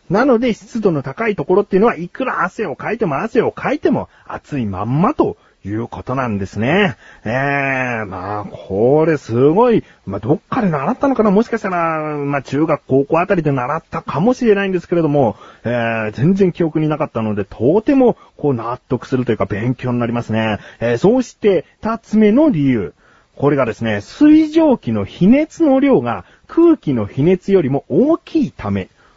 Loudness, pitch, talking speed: -16 LUFS, 150 Hz, 360 characters per minute